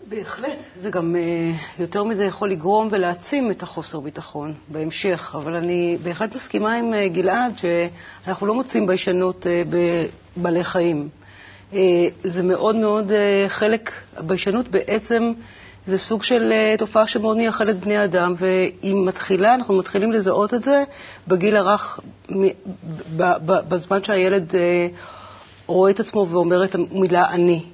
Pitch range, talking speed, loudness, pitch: 175-210 Hz, 120 wpm, -20 LUFS, 190 Hz